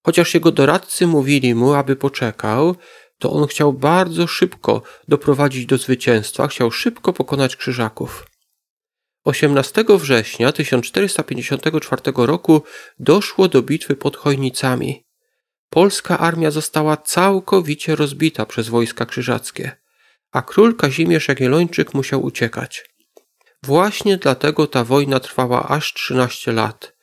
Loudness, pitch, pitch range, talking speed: -17 LUFS, 145 Hz, 130-165 Hz, 110 wpm